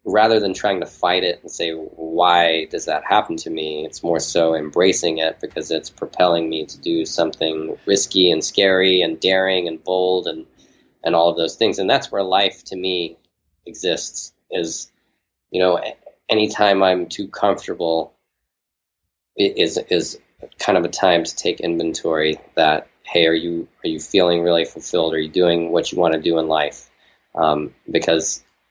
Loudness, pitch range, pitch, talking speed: -19 LUFS, 80-90 Hz, 85 Hz, 175 wpm